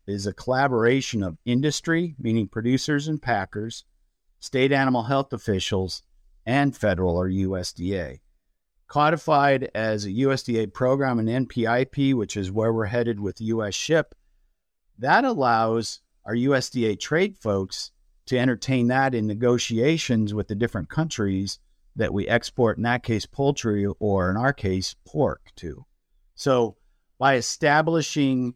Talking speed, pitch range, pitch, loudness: 130 wpm, 100-130 Hz, 115 Hz, -24 LUFS